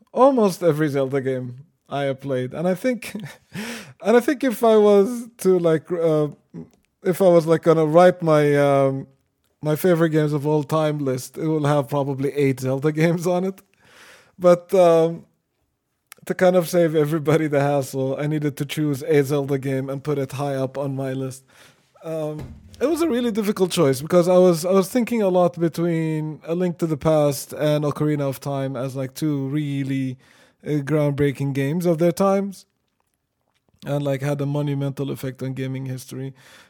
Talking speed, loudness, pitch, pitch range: 180 wpm, -21 LUFS, 150 Hz, 140-175 Hz